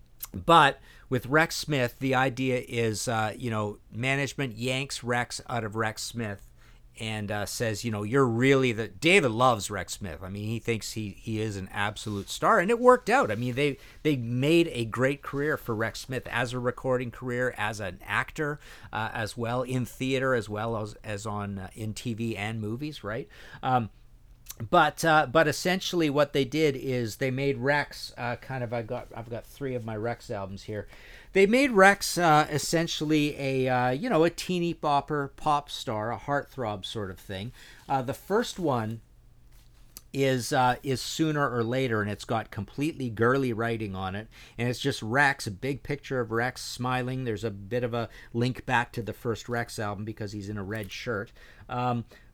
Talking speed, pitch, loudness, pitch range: 195 wpm, 120 Hz, -28 LUFS, 110-140 Hz